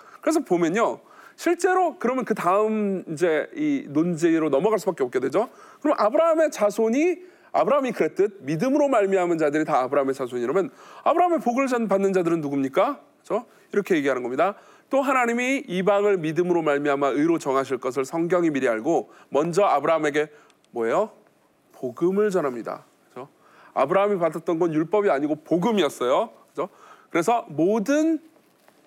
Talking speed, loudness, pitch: 375 characters per minute, -23 LUFS, 200 Hz